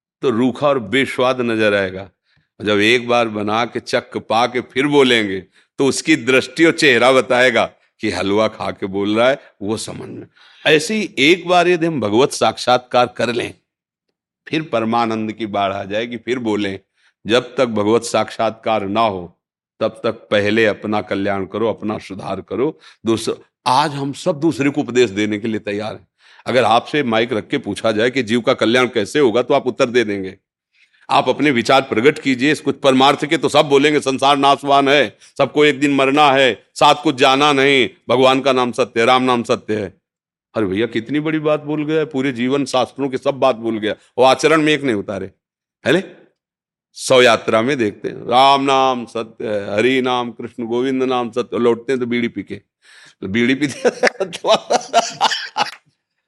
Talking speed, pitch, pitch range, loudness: 180 wpm, 125 Hz, 110-140 Hz, -16 LUFS